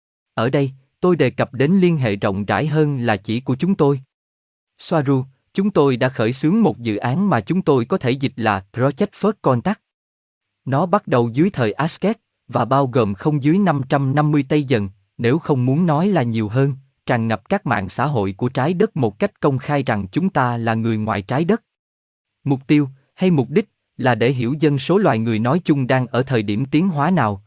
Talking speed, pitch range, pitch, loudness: 215 wpm, 115-155 Hz, 135 Hz, -19 LUFS